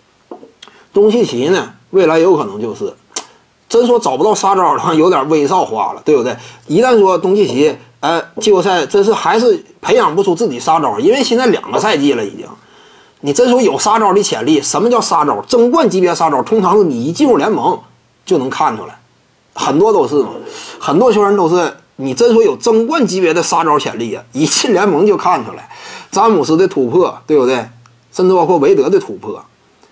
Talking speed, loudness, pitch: 295 characters per minute, -12 LUFS, 235 Hz